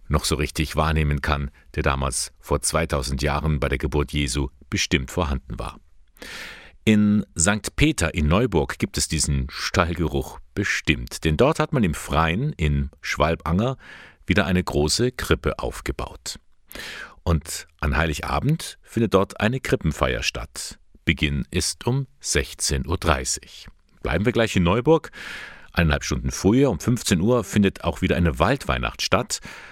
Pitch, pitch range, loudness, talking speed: 80 Hz, 75-95 Hz, -23 LUFS, 140 wpm